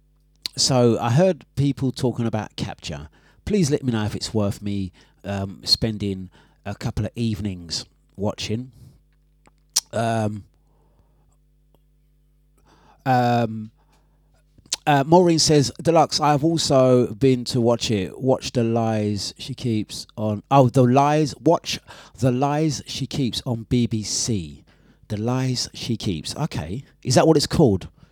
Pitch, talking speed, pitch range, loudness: 125 Hz, 130 wpm, 105-145 Hz, -21 LUFS